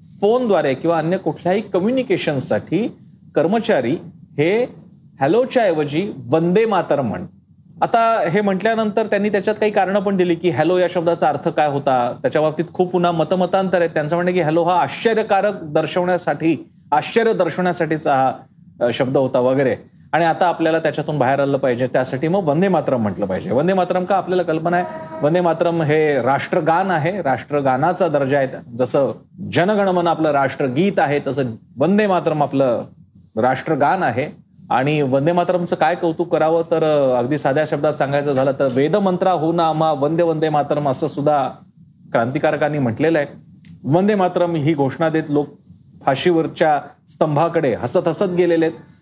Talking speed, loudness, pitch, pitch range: 150 wpm, -18 LUFS, 165 Hz, 150-180 Hz